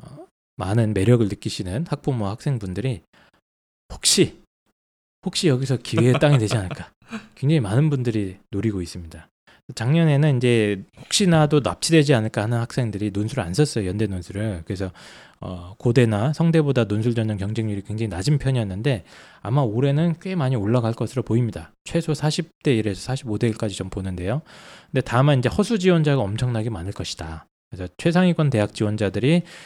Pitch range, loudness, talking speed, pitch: 100-145 Hz, -22 LUFS, 360 characters per minute, 115 Hz